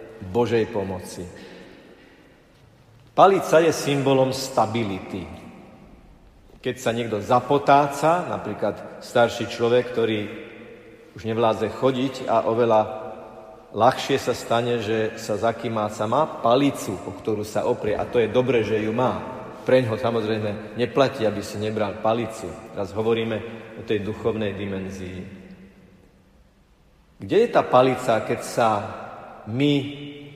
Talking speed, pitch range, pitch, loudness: 120 wpm, 105-125 Hz, 115 Hz, -22 LUFS